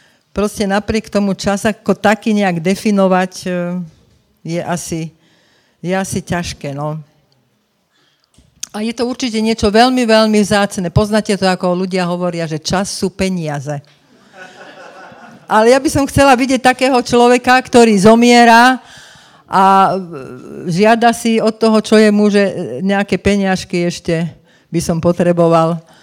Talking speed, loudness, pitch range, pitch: 130 wpm, -13 LUFS, 175-220 Hz, 195 Hz